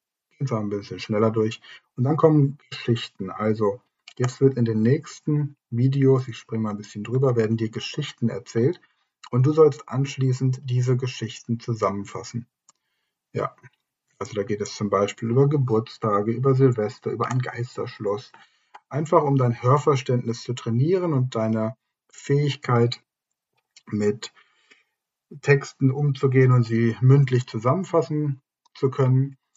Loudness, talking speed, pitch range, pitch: -23 LUFS, 130 wpm, 115-140 Hz, 125 Hz